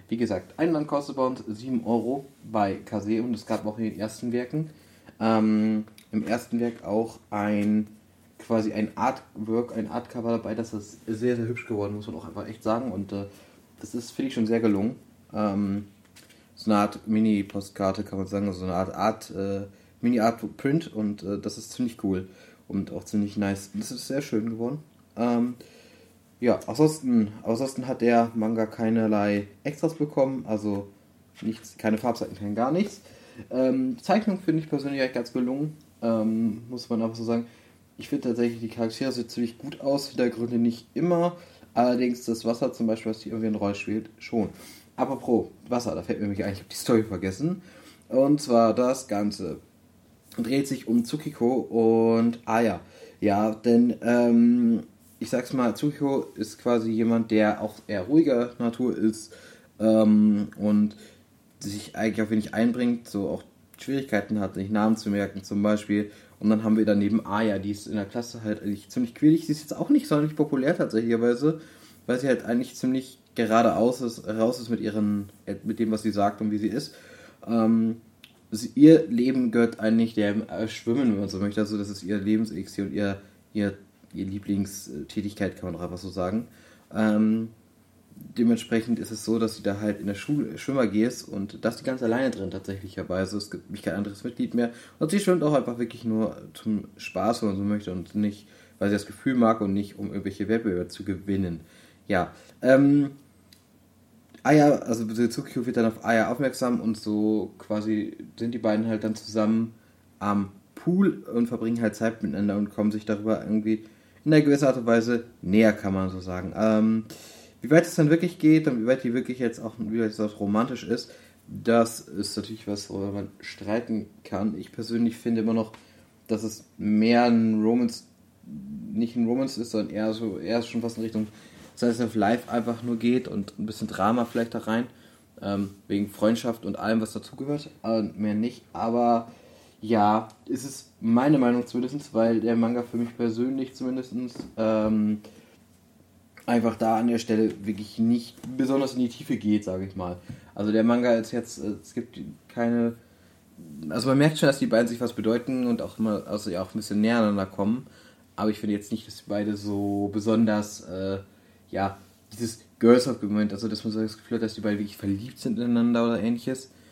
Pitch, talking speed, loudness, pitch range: 110 Hz, 190 wpm, -26 LUFS, 105-120 Hz